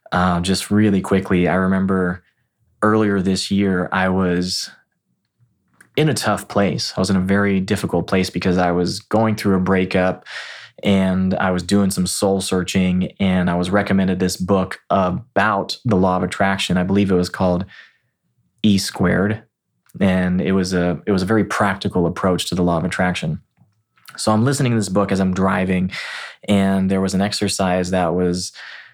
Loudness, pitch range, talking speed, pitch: -18 LUFS, 90-100 Hz, 175 wpm, 95 Hz